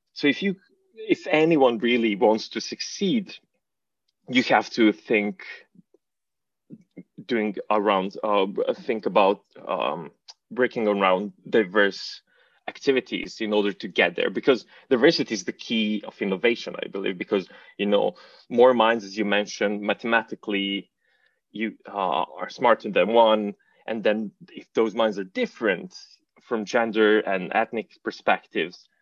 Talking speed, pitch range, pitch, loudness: 130 wpm, 105-125 Hz, 110 Hz, -24 LUFS